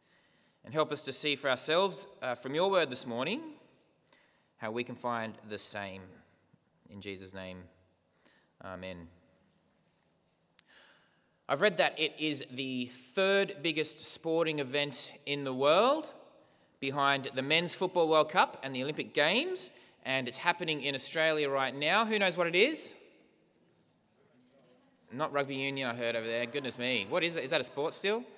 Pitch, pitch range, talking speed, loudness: 140 Hz, 120-170 Hz, 160 wpm, -31 LUFS